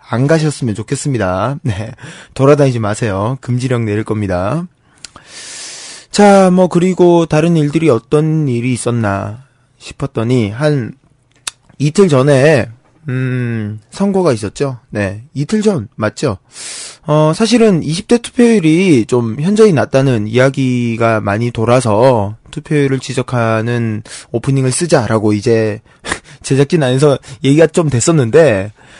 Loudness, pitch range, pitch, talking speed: -13 LUFS, 115-155 Hz, 130 Hz, 255 characters per minute